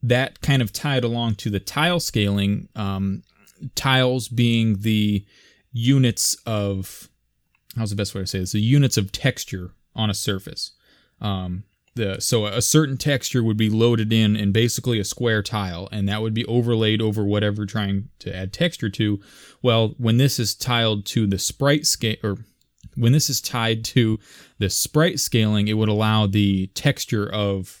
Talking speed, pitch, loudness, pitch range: 175 wpm, 110 Hz, -21 LUFS, 100-120 Hz